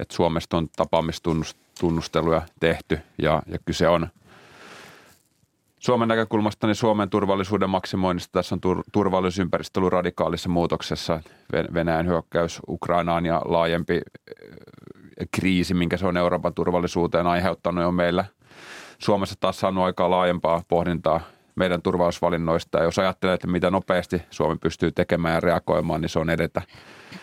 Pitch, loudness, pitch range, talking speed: 85 Hz, -23 LUFS, 85-95 Hz, 130 wpm